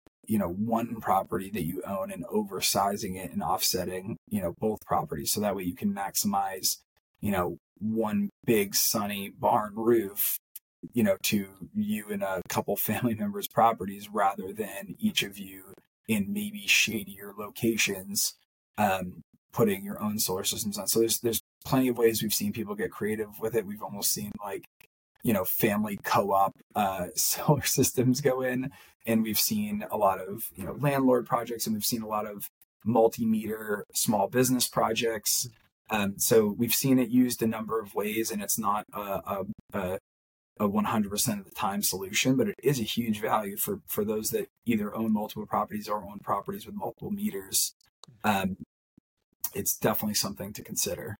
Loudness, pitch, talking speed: -28 LUFS, 115 Hz, 175 wpm